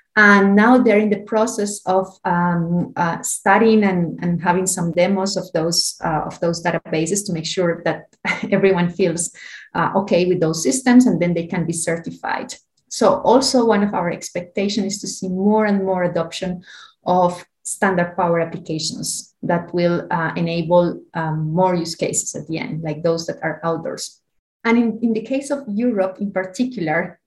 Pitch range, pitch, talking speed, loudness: 170-205 Hz, 180 Hz, 175 wpm, -19 LUFS